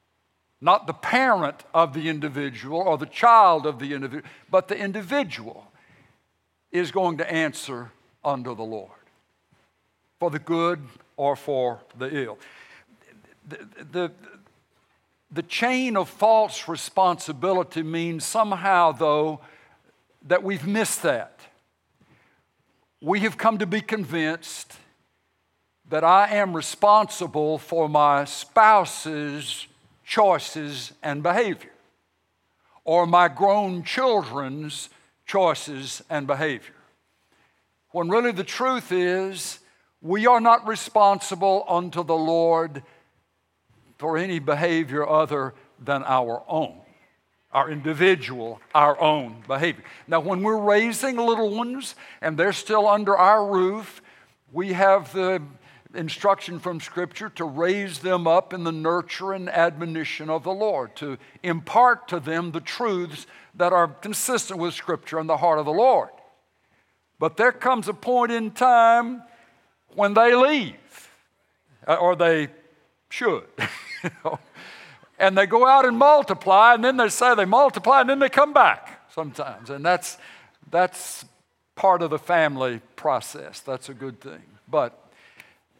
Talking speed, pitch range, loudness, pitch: 125 wpm, 150-205 Hz, -22 LUFS, 170 Hz